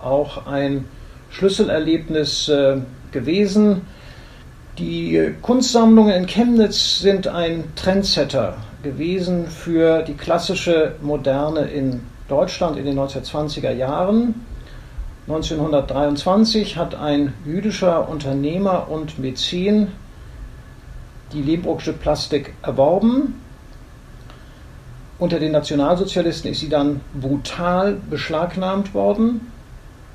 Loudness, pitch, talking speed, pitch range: -19 LUFS, 155 Hz, 85 wpm, 140-185 Hz